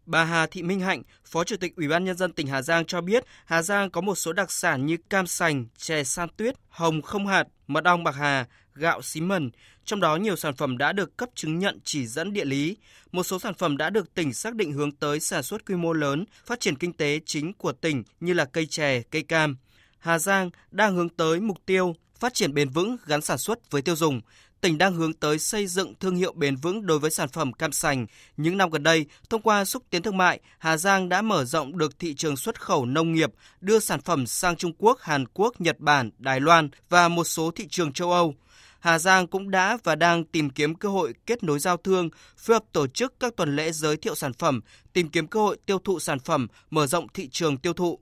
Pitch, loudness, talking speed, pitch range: 165 Hz, -25 LUFS, 245 wpm, 150-185 Hz